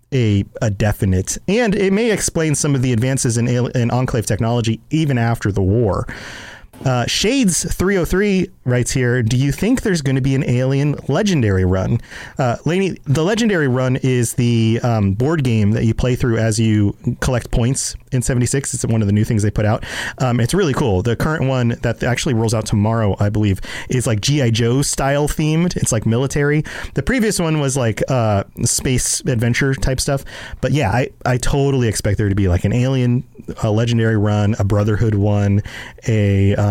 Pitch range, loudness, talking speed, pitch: 110-140 Hz, -17 LUFS, 190 wpm, 125 Hz